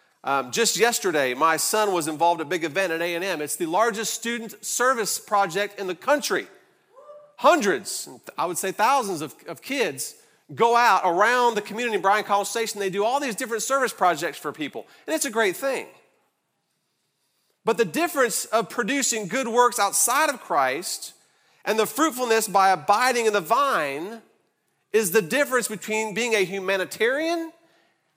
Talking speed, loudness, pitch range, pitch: 175 wpm, -23 LUFS, 195-255 Hz, 225 Hz